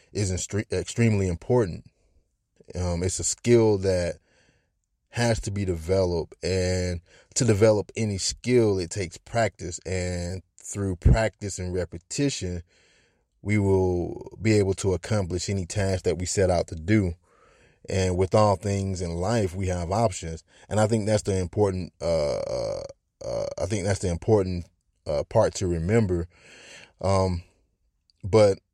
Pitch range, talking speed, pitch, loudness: 90-105 Hz, 140 wpm, 95 Hz, -25 LUFS